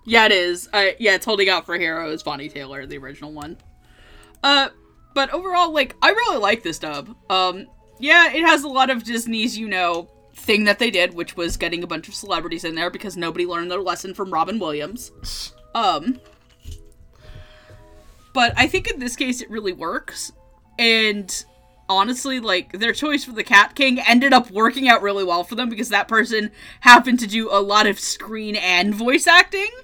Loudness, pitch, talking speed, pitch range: -18 LUFS, 205 Hz, 190 wpm, 170-245 Hz